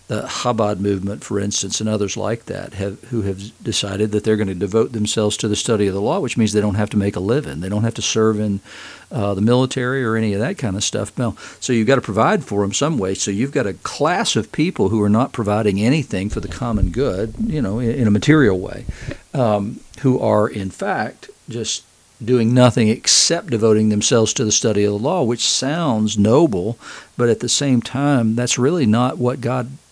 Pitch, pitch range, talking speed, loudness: 110 Hz, 105-125 Hz, 225 wpm, -18 LUFS